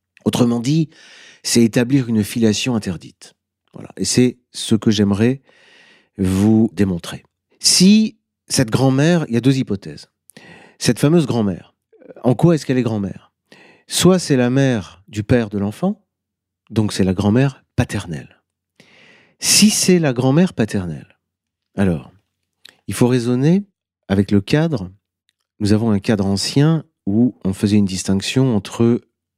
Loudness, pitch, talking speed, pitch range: -17 LUFS, 115 Hz, 140 wpm, 100-135 Hz